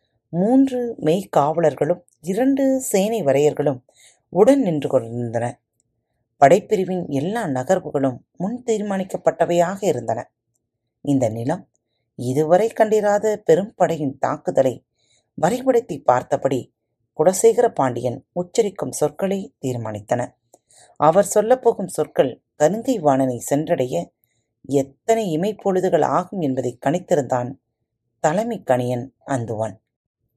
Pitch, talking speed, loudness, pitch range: 155 Hz, 85 wpm, -20 LUFS, 125-195 Hz